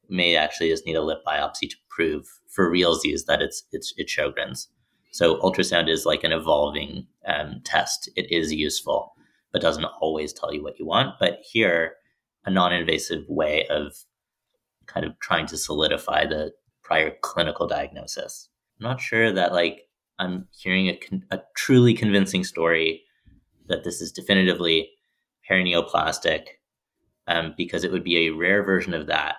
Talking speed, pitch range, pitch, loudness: 155 wpm, 80-95 Hz, 90 Hz, -23 LUFS